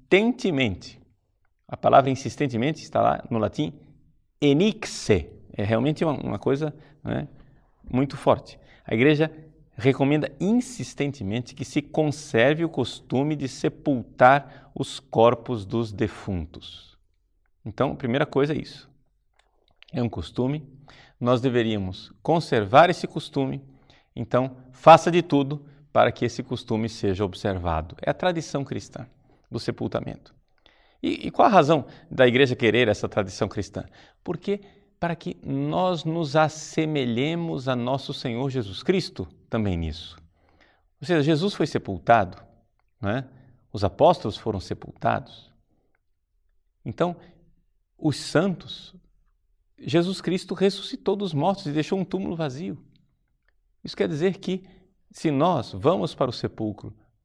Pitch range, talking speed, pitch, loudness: 110-155 Hz, 125 wpm, 135 Hz, -24 LUFS